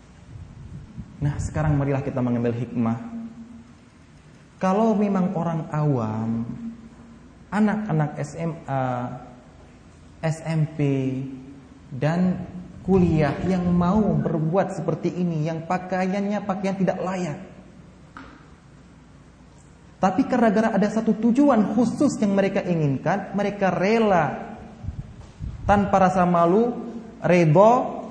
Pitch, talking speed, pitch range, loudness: 180 Hz, 90 wpm, 150-200 Hz, -22 LUFS